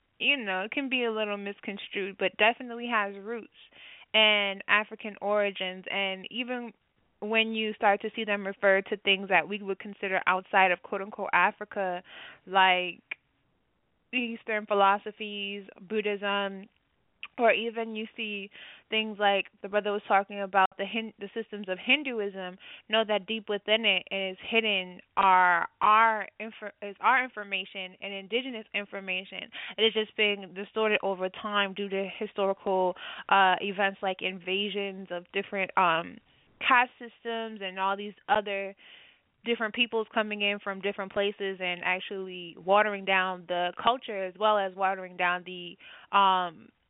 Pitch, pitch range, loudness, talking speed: 200 Hz, 195-220 Hz, -28 LUFS, 145 wpm